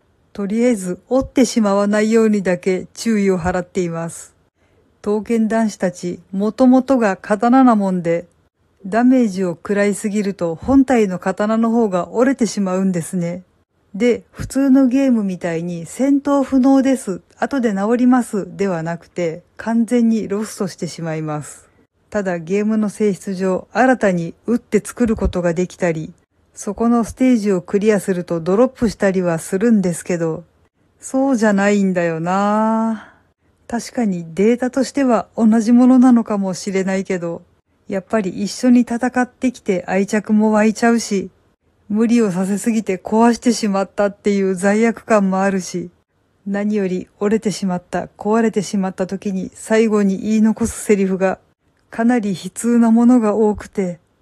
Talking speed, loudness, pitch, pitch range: 320 characters per minute, -17 LUFS, 205 Hz, 185-230 Hz